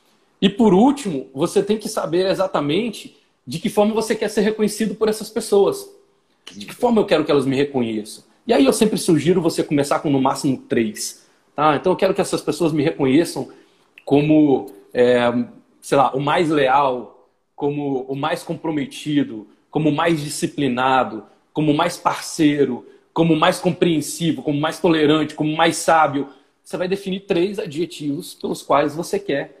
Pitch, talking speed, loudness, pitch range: 165 Hz, 170 wpm, -19 LUFS, 145-195 Hz